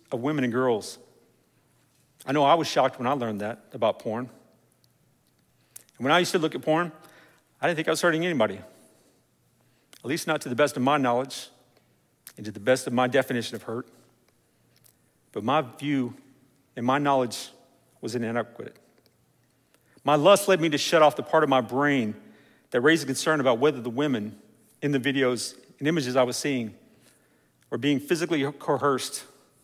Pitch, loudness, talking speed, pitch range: 135 Hz, -25 LUFS, 180 wpm, 125-150 Hz